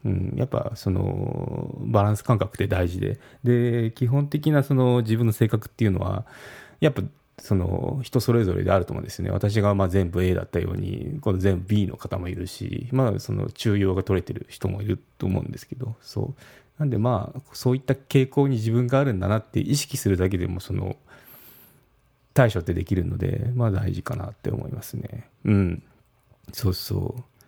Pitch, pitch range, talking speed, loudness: 115 Hz, 100-125 Hz, 360 characters per minute, -25 LUFS